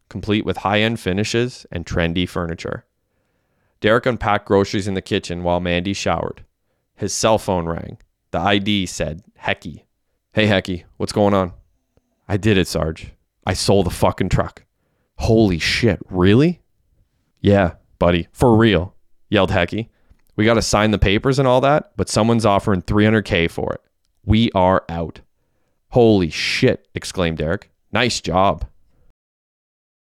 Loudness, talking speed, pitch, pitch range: -18 LUFS, 145 wpm, 100 Hz, 90-110 Hz